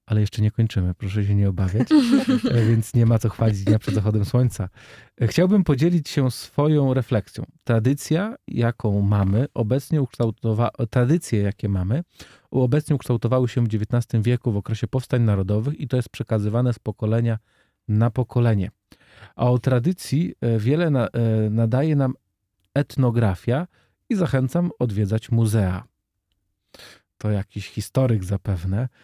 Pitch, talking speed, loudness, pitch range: 115 Hz, 130 wpm, -22 LUFS, 105-130 Hz